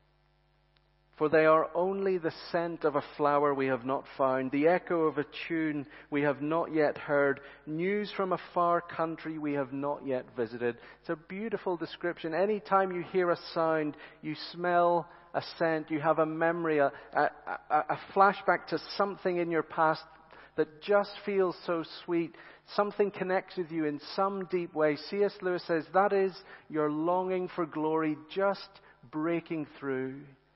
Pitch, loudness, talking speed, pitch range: 165 Hz, -31 LUFS, 165 wpm, 150-180 Hz